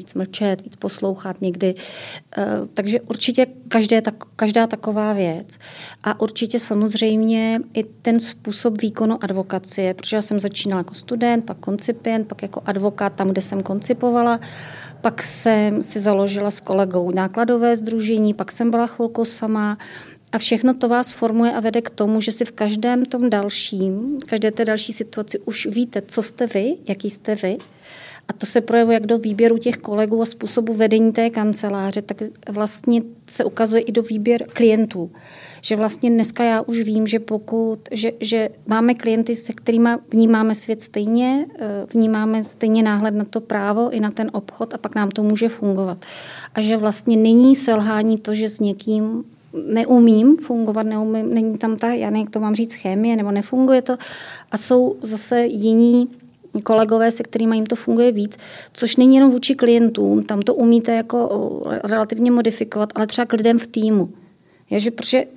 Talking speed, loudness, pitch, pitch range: 165 wpm, -19 LUFS, 225 Hz, 210-235 Hz